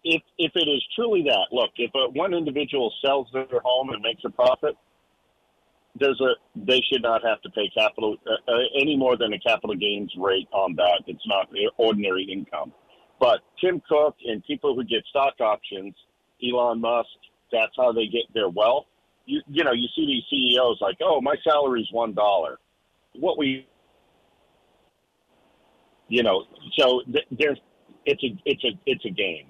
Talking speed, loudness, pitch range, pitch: 180 wpm, -23 LUFS, 110-155 Hz, 130 Hz